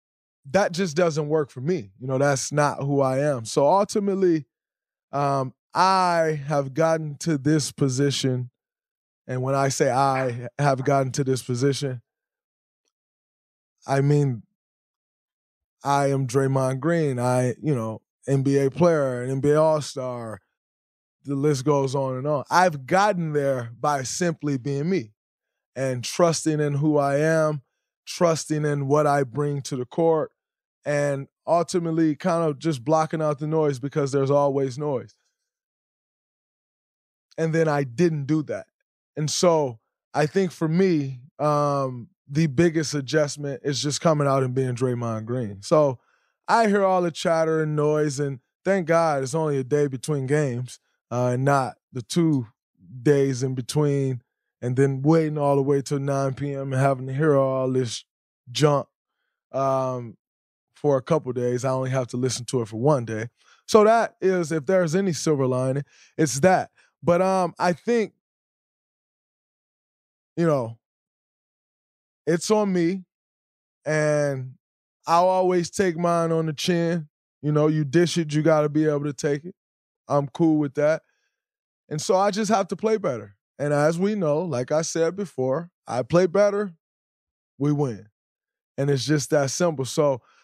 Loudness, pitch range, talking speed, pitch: -23 LUFS, 135-165 Hz, 160 wpm, 145 Hz